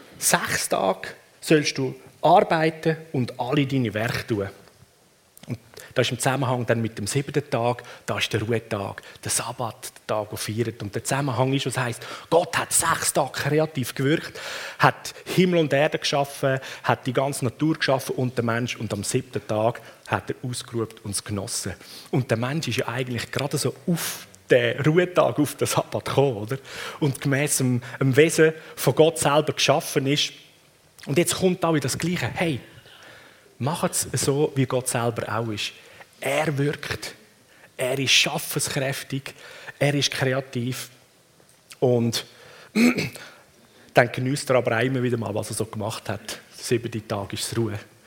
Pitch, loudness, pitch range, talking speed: 130 Hz, -24 LUFS, 115-145 Hz, 165 wpm